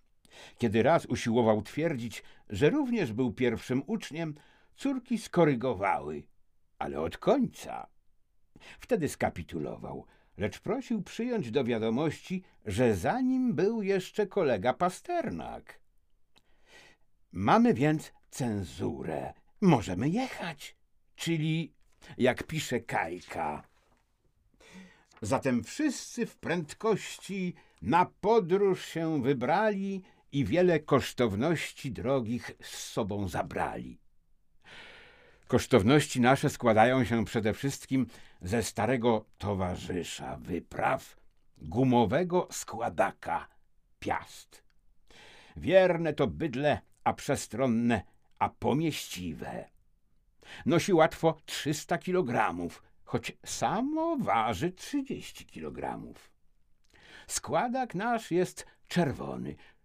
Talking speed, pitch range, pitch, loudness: 85 wpm, 115-185 Hz, 140 Hz, -30 LUFS